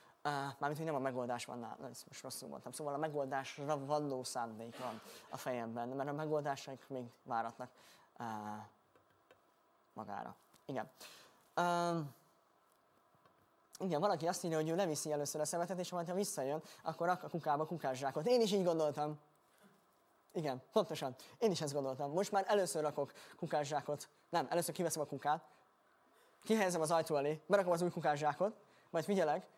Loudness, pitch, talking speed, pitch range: -39 LUFS, 150 Hz, 155 wpm, 135-175 Hz